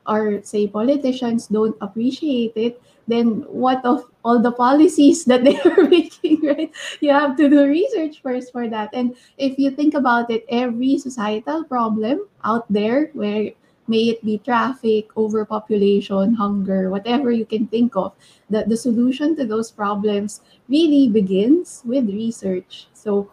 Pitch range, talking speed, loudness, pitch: 215-275 Hz, 150 wpm, -19 LUFS, 235 Hz